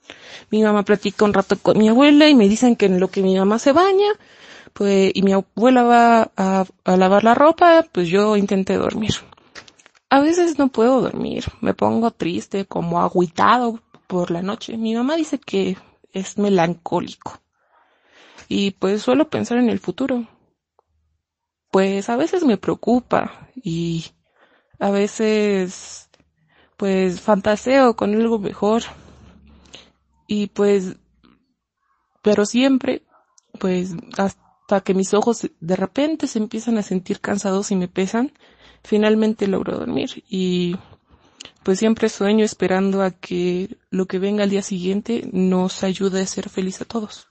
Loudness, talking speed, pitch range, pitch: -18 LUFS, 145 wpm, 190-230 Hz, 205 Hz